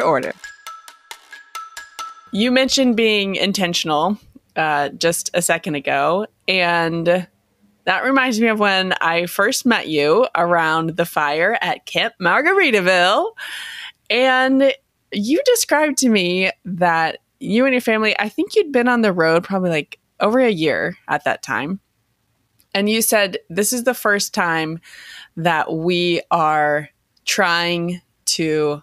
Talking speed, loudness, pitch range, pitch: 135 wpm, -17 LUFS, 165-250 Hz, 195 Hz